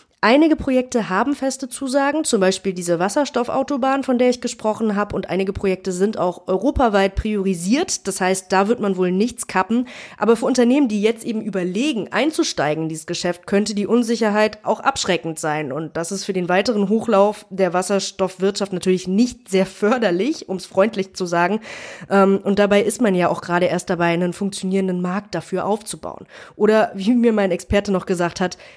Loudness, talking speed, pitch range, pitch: -19 LUFS, 180 wpm, 185-235 Hz, 200 Hz